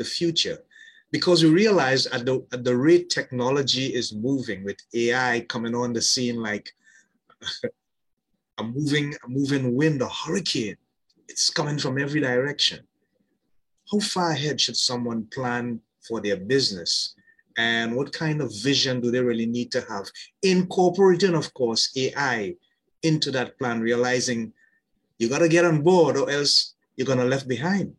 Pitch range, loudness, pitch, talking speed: 120-155 Hz, -23 LUFS, 130 Hz, 155 wpm